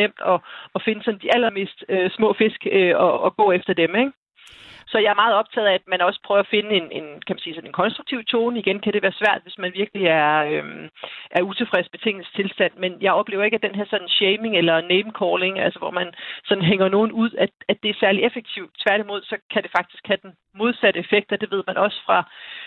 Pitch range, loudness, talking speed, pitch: 185-220 Hz, -20 LUFS, 240 wpm, 200 Hz